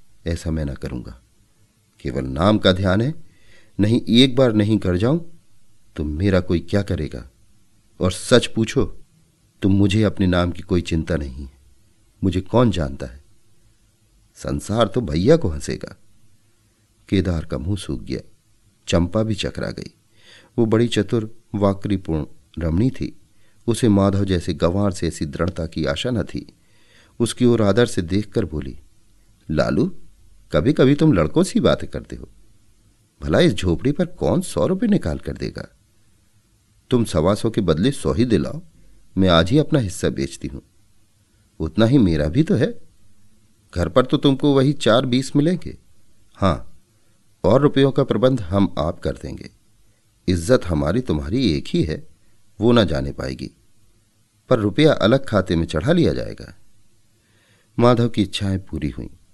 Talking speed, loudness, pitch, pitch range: 155 wpm, -20 LUFS, 105 Hz, 90-110 Hz